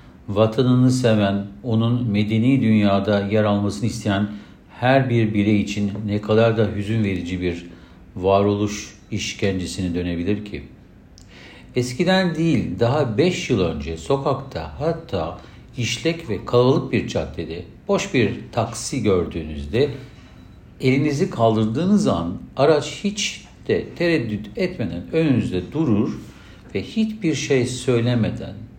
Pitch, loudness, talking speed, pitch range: 110 Hz, -21 LUFS, 110 wpm, 100-135 Hz